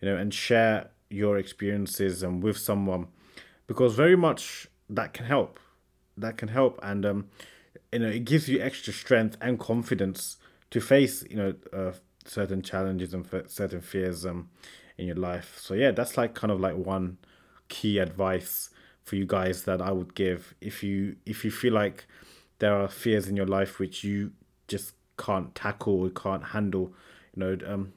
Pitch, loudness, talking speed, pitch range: 100 Hz, -29 LUFS, 180 wpm, 95-110 Hz